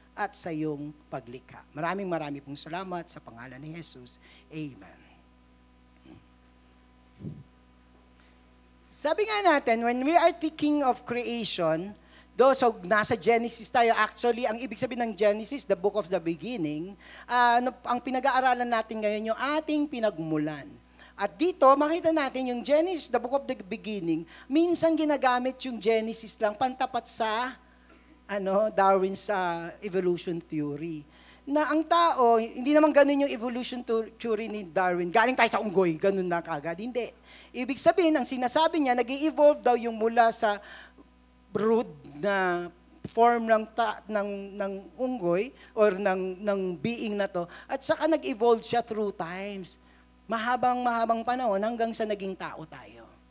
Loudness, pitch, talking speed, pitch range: -27 LUFS, 220 Hz, 145 wpm, 170-250 Hz